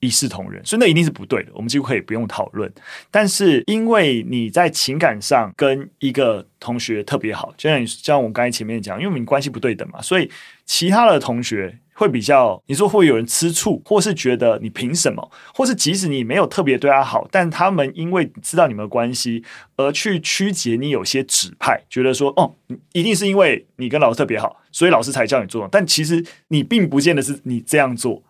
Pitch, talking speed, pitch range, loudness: 140 Hz, 325 characters per minute, 125-180 Hz, -18 LUFS